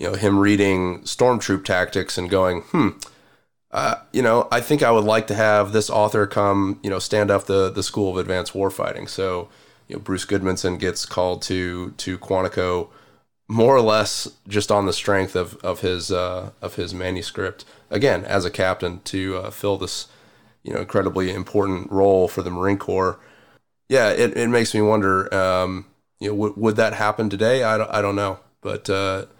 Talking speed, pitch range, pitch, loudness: 190 wpm, 95-105 Hz, 95 Hz, -21 LUFS